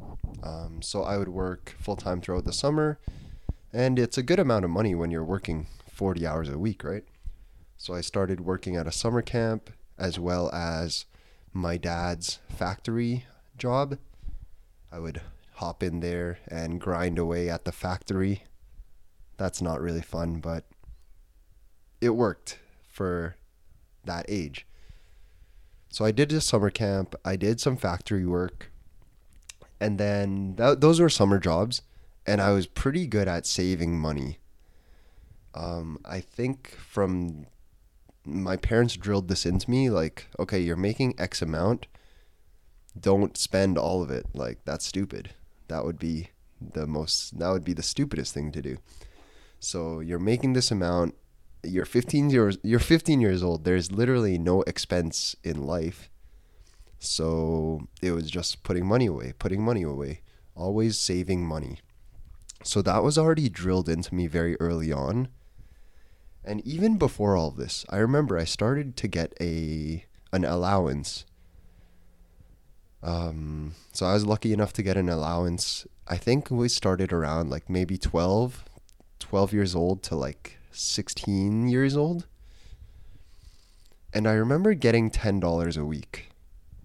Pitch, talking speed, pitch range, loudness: 90 Hz, 145 wpm, 80-105 Hz, -27 LUFS